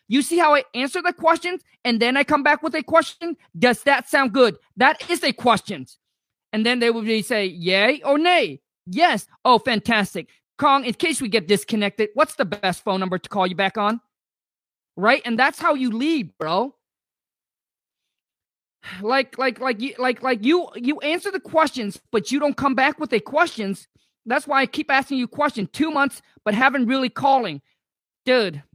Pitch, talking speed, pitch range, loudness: 260 Hz, 190 wpm, 215-295 Hz, -20 LUFS